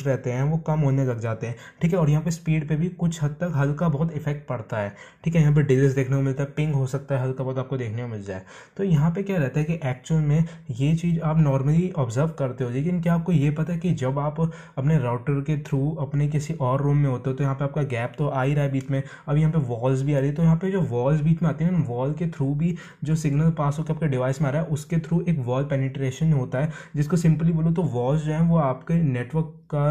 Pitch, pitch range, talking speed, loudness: 150 Hz, 135-160 Hz, 210 wpm, -24 LUFS